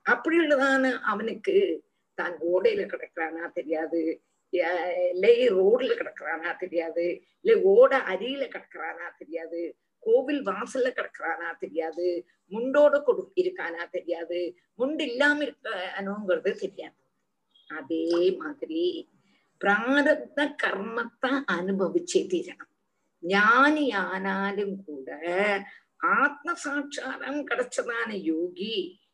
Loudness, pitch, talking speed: -26 LUFS, 250 Hz, 75 wpm